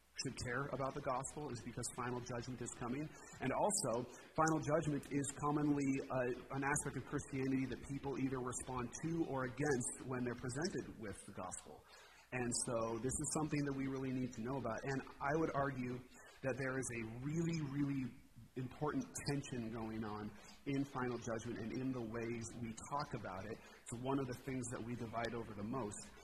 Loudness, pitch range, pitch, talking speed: -42 LUFS, 120-140 Hz, 130 Hz, 190 wpm